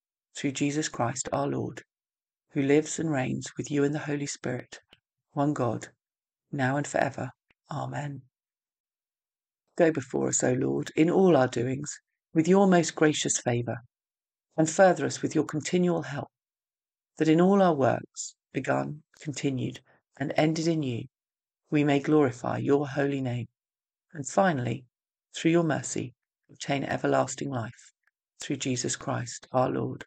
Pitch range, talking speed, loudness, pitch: 130-160 Hz, 145 wpm, -27 LUFS, 145 Hz